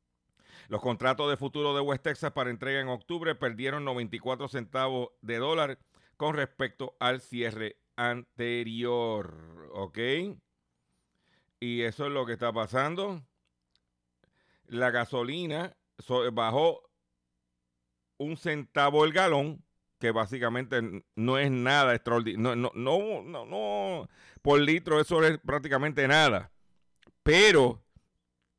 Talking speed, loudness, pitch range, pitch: 115 wpm, -29 LUFS, 110-140 Hz, 125 Hz